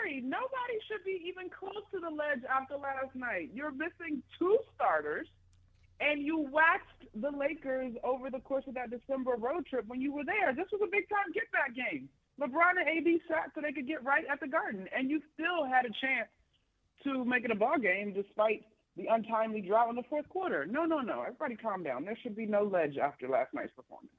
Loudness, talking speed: -33 LUFS, 215 wpm